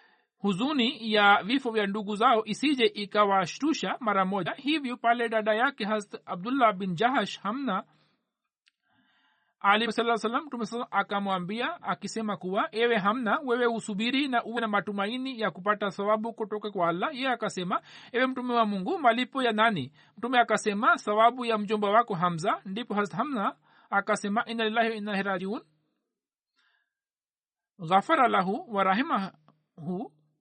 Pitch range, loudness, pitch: 200-240 Hz, -27 LUFS, 220 Hz